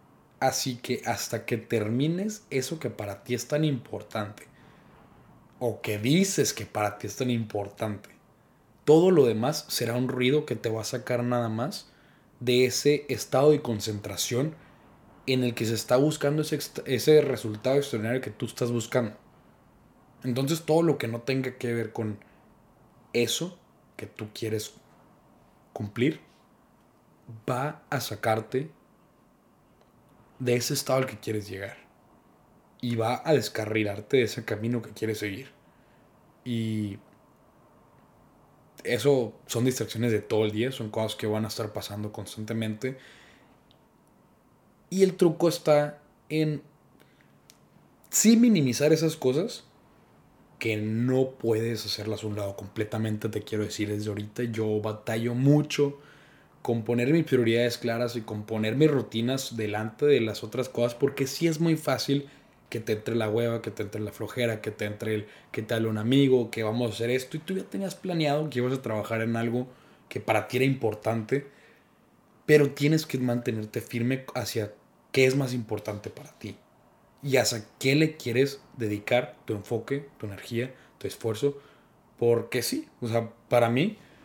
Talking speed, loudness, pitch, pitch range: 155 wpm, -27 LUFS, 120 Hz, 110-140 Hz